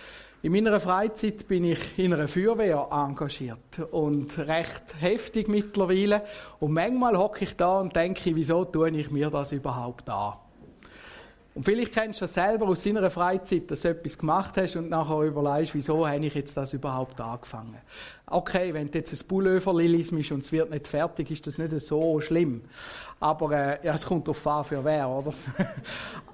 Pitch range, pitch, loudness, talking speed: 145-185 Hz, 160 Hz, -27 LUFS, 175 wpm